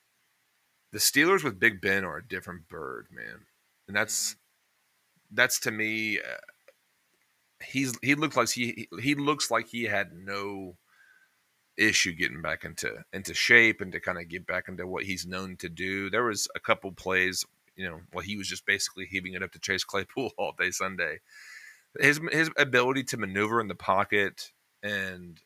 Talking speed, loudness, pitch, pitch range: 175 wpm, -27 LUFS, 100 Hz, 95-125 Hz